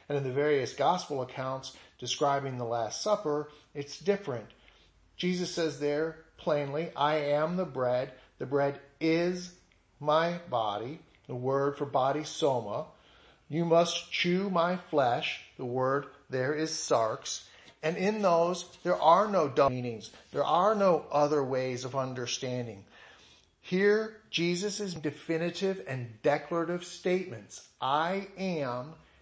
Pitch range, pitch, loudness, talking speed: 130-175 Hz, 150 Hz, -30 LUFS, 130 wpm